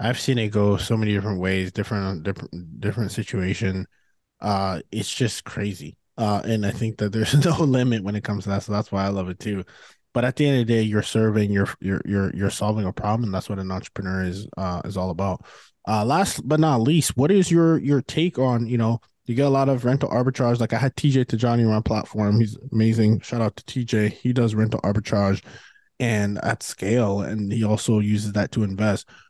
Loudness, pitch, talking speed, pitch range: -23 LUFS, 110 Hz, 225 wpm, 100-120 Hz